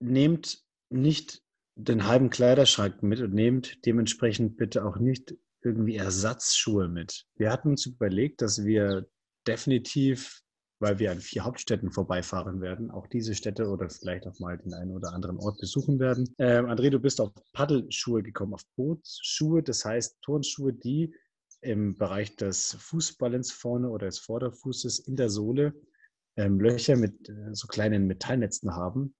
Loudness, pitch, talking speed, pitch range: -28 LUFS, 115 Hz, 155 wpm, 100-130 Hz